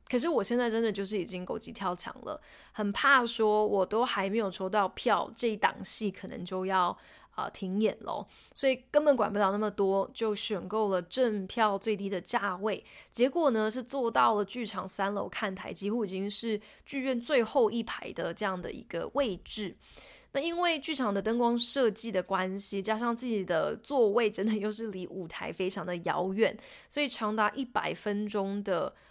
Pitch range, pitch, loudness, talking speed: 195-235 Hz, 215 Hz, -30 LUFS, 275 characters per minute